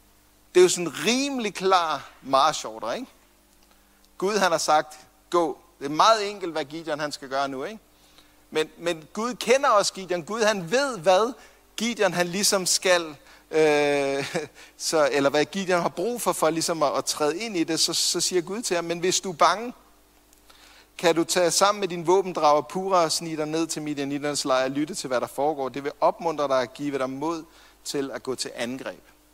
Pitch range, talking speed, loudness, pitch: 150-190 Hz, 205 wpm, -24 LUFS, 165 Hz